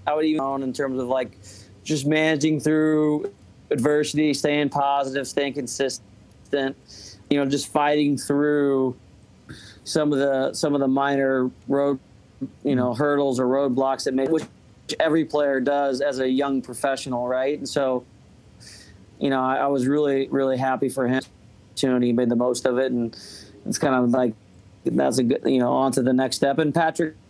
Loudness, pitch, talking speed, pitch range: -23 LUFS, 135 Hz, 180 wpm, 125-145 Hz